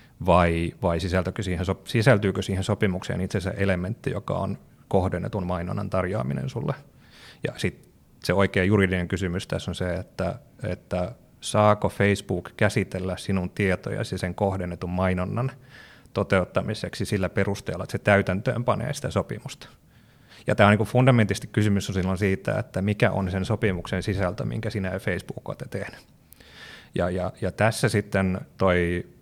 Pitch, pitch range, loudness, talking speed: 95 Hz, 90-105 Hz, -25 LUFS, 140 wpm